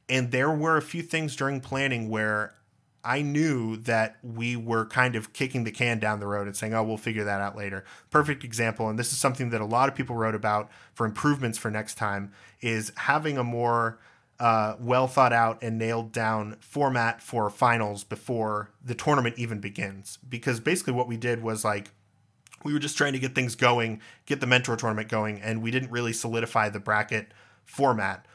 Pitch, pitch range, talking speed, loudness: 115 Hz, 110-130 Hz, 200 wpm, -27 LUFS